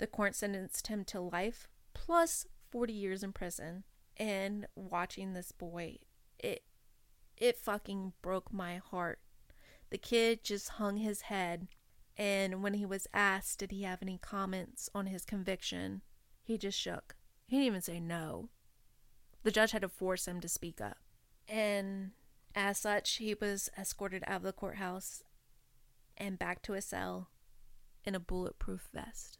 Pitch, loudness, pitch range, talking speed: 195 Hz, -38 LUFS, 180-205 Hz, 155 wpm